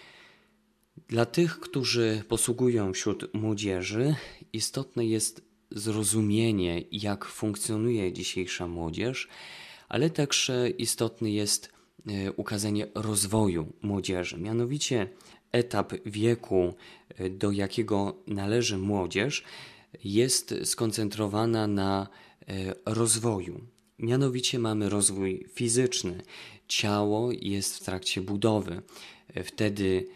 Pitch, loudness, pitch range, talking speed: 110 Hz, -29 LUFS, 100-120 Hz, 80 wpm